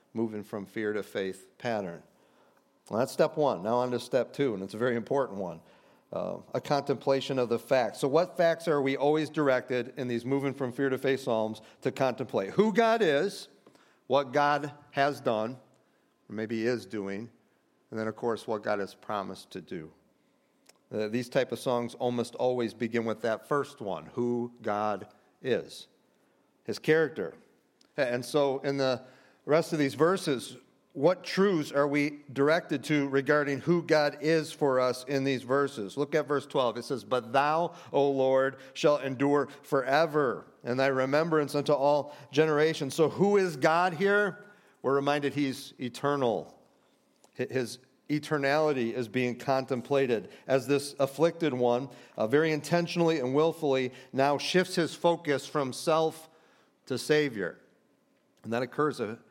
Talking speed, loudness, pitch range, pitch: 160 wpm, -29 LUFS, 125-150 Hz, 140 Hz